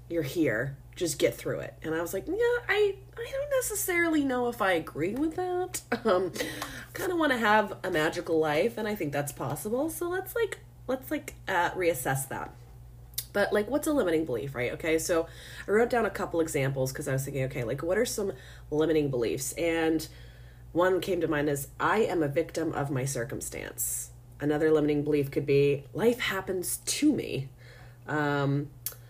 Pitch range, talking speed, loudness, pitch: 135-220 Hz, 190 wpm, -29 LUFS, 160 Hz